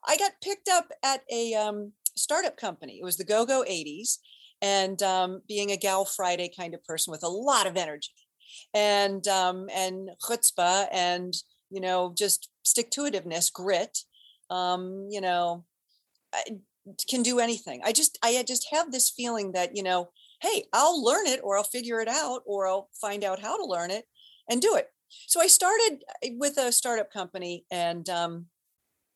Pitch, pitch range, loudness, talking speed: 200 Hz, 180-245 Hz, -27 LUFS, 175 wpm